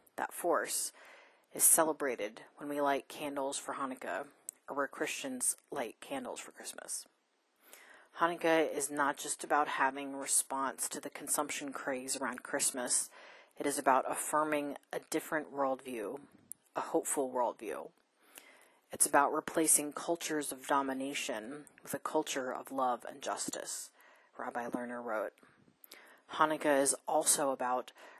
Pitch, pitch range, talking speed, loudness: 145 Hz, 135-160 Hz, 130 wpm, -34 LUFS